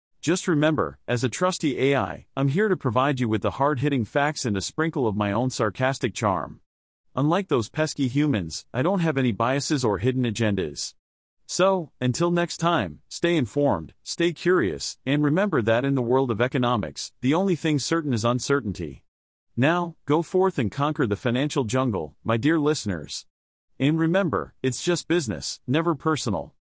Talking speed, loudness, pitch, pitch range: 170 wpm, -24 LUFS, 130 Hz, 110-155 Hz